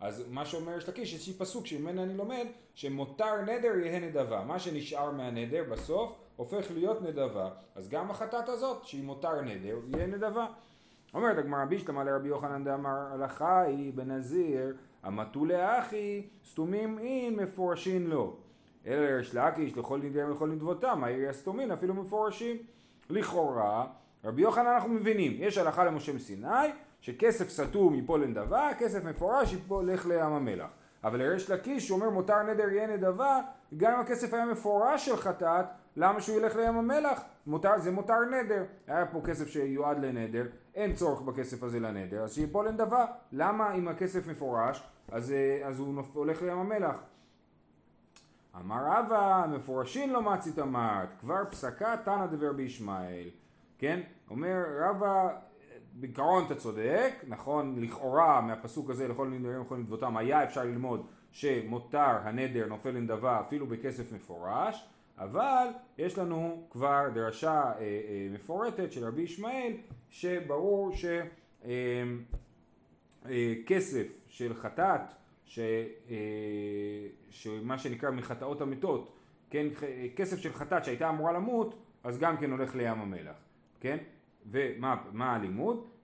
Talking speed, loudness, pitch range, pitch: 135 wpm, -32 LUFS, 130-205 Hz, 160 Hz